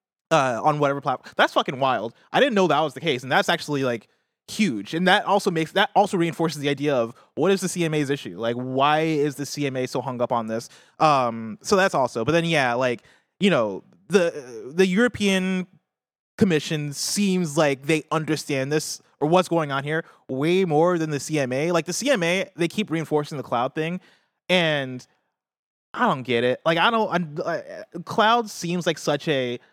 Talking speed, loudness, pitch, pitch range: 195 wpm, -23 LUFS, 160 Hz, 145-185 Hz